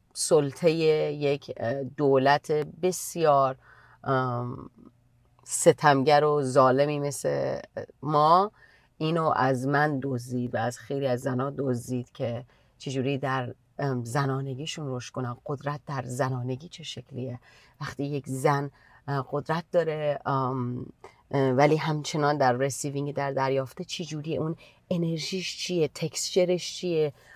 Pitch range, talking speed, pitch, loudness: 130-150 Hz, 105 wpm, 140 Hz, -27 LUFS